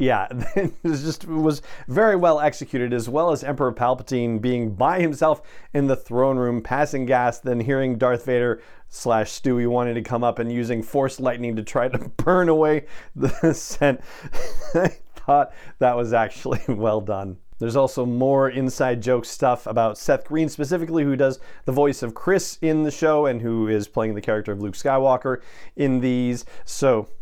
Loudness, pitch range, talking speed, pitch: -22 LUFS, 120-150 Hz, 180 wpm, 130 Hz